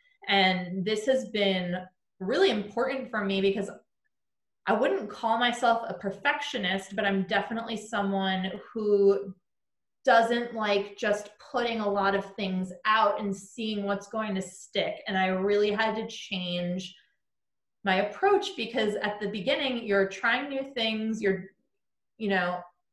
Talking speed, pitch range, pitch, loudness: 140 wpm, 195-230 Hz, 205 Hz, -28 LUFS